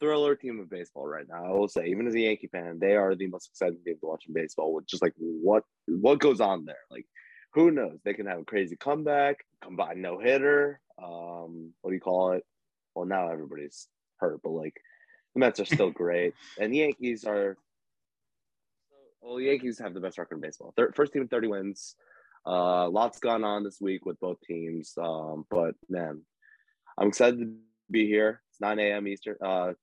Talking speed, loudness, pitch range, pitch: 200 wpm, -29 LUFS, 85-120 Hz, 100 Hz